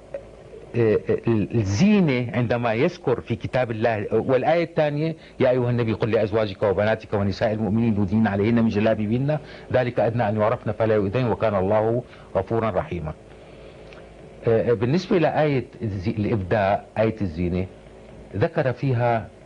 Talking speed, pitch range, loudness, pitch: 115 wpm, 105-125 Hz, -22 LUFS, 115 Hz